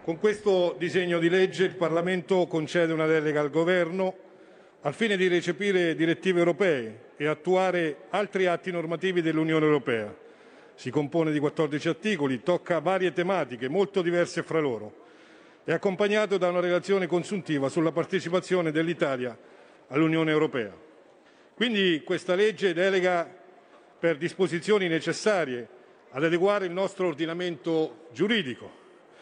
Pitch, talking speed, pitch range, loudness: 175 Hz, 125 wpm, 160-185 Hz, -26 LUFS